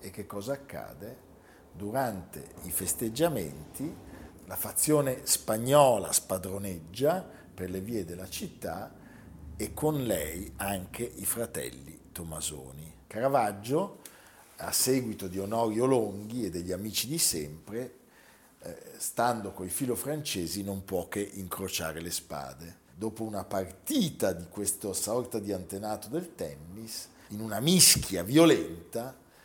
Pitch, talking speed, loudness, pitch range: 100 Hz, 120 wpm, -30 LUFS, 90-120 Hz